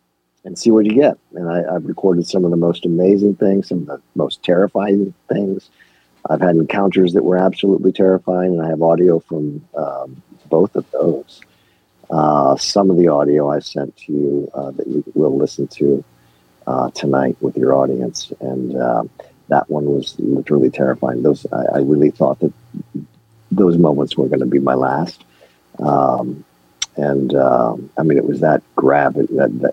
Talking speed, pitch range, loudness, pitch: 180 wpm, 65-90 Hz, -16 LUFS, 75 Hz